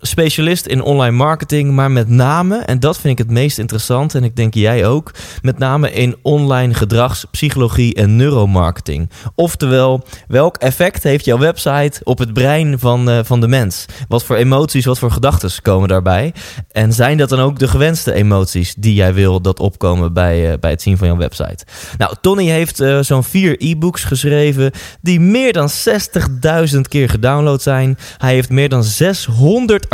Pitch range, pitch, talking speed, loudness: 110-145 Hz, 130 Hz, 180 wpm, -13 LUFS